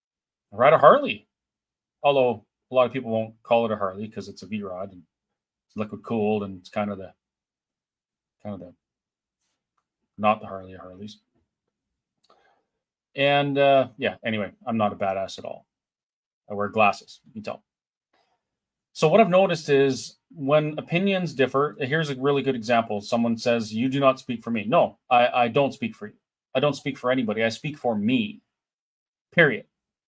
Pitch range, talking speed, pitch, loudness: 105-145 Hz, 175 wpm, 125 Hz, -23 LUFS